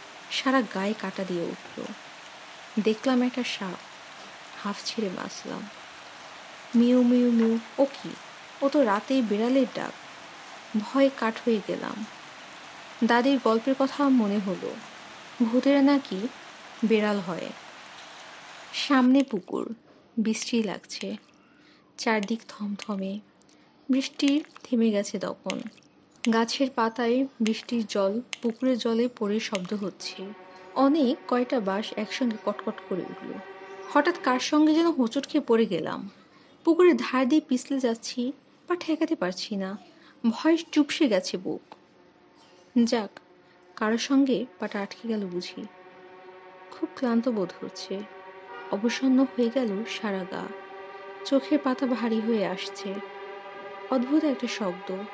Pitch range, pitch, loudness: 200-265 Hz, 230 Hz, -27 LUFS